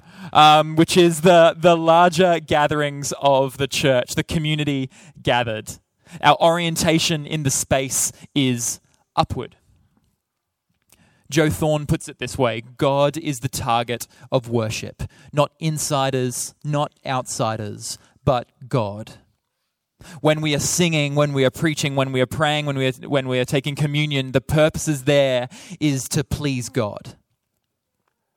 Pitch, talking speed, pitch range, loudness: 140 Hz, 140 wpm, 125-155 Hz, -20 LUFS